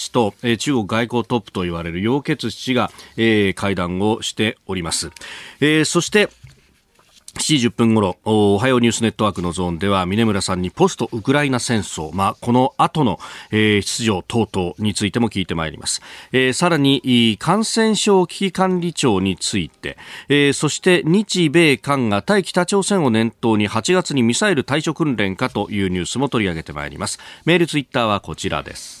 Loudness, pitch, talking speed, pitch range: -18 LUFS, 115 Hz, 335 characters per minute, 100-145 Hz